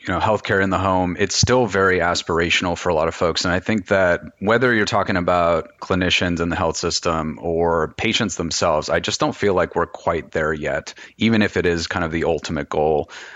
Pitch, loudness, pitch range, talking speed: 95 Hz, -19 LUFS, 85-105 Hz, 220 wpm